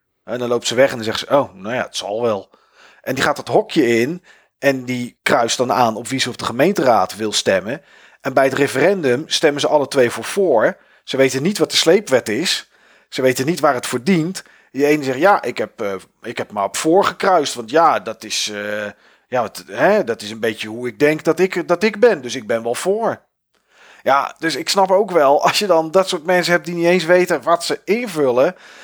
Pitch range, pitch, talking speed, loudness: 120-175 Hz, 140 Hz, 240 wpm, -17 LUFS